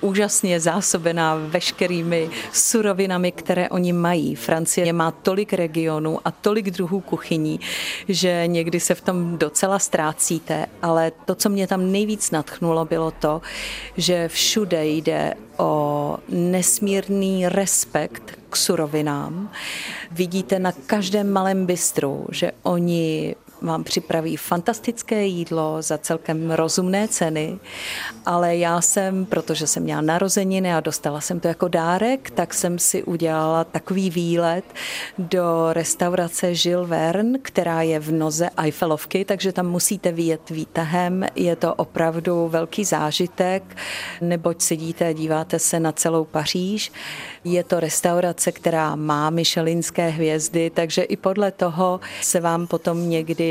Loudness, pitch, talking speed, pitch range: -21 LUFS, 175 Hz, 130 wpm, 165-190 Hz